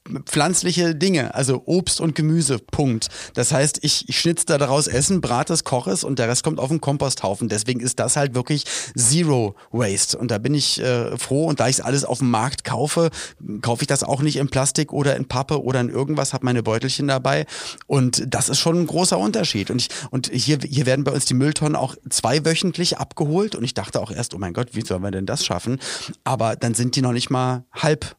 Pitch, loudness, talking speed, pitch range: 135 Hz, -20 LUFS, 230 wpm, 120-150 Hz